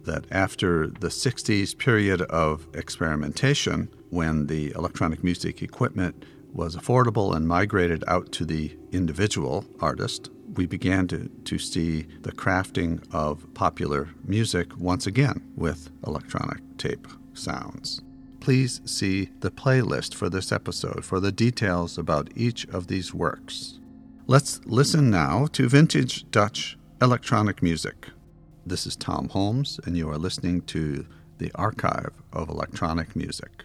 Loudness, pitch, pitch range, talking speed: -26 LUFS, 95 Hz, 85-125 Hz, 130 wpm